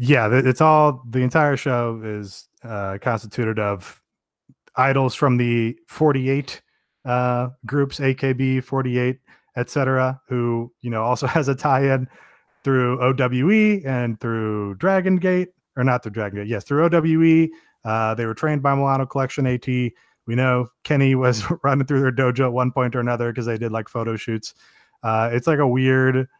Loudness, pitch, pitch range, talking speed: -21 LUFS, 125 Hz, 120-140 Hz, 160 wpm